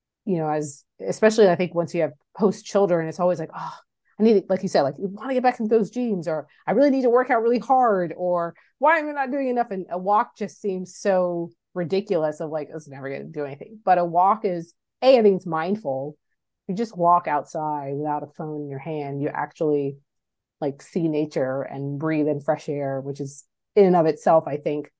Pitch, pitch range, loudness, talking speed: 170 Hz, 150-200 Hz, -23 LUFS, 235 wpm